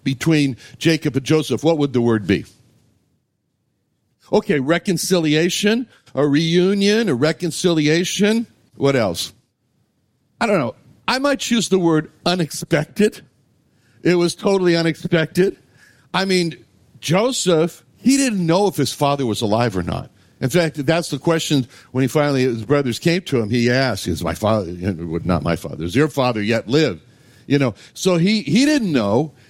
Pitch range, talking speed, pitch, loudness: 125-175 Hz, 155 wpm, 155 Hz, -19 LUFS